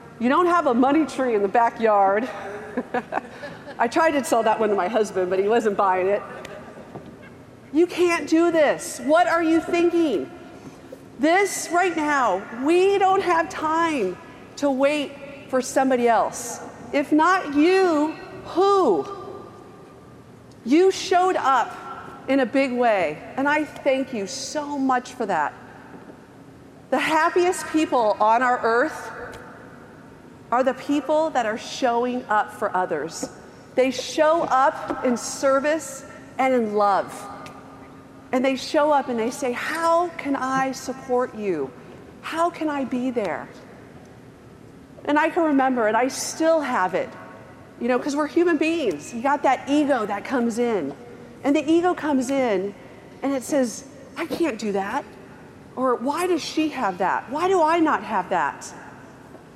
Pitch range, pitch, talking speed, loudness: 245-320 Hz, 275 Hz, 150 wpm, -22 LUFS